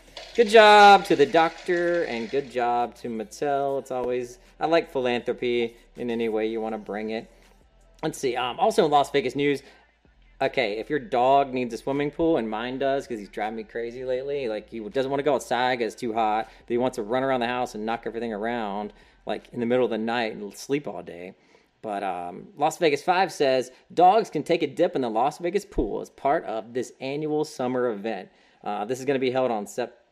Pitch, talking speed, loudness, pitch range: 130 Hz, 225 wpm, -24 LUFS, 115-145 Hz